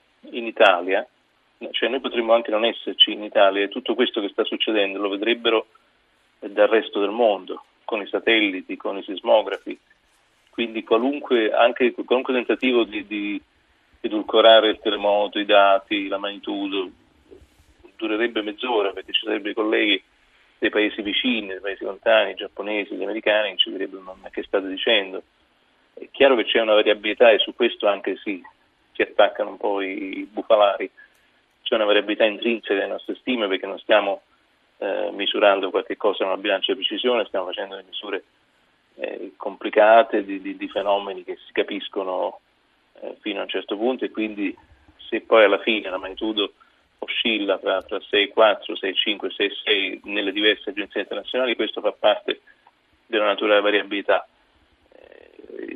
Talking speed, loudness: 160 wpm, -21 LUFS